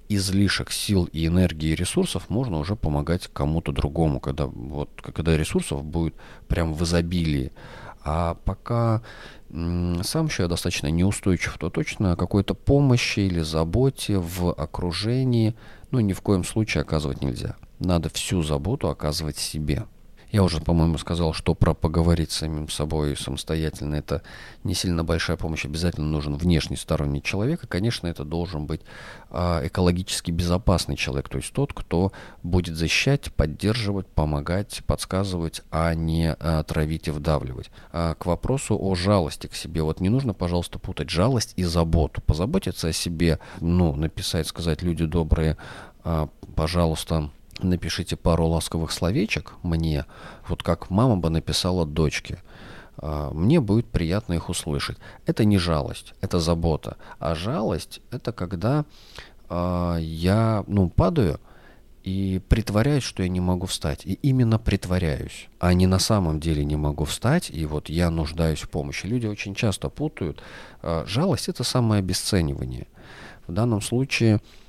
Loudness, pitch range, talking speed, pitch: -24 LUFS, 80-100 Hz, 140 wpm, 85 Hz